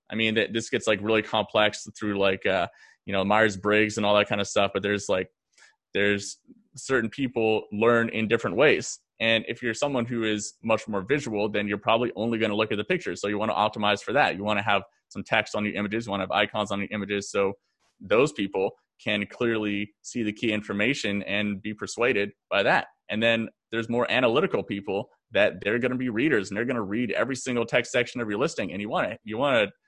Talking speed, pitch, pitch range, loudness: 235 wpm, 110 Hz, 105-115 Hz, -26 LUFS